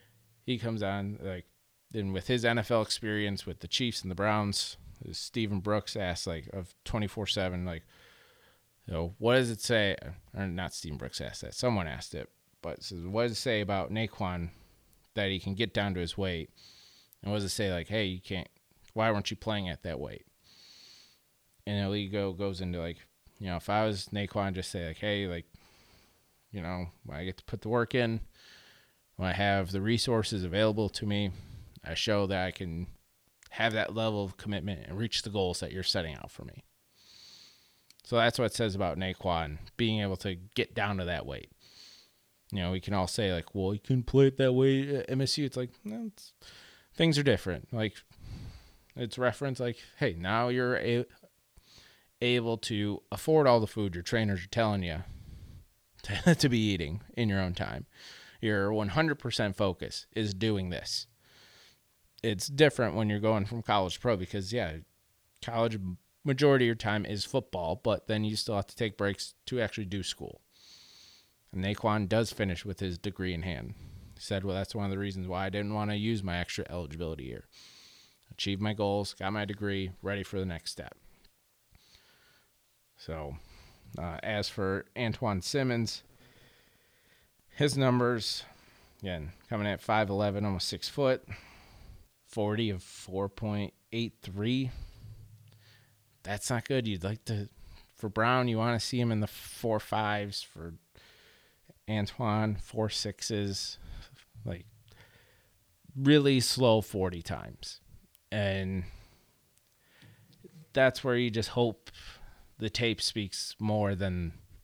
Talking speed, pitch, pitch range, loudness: 170 wpm, 105 Hz, 95-115 Hz, -32 LUFS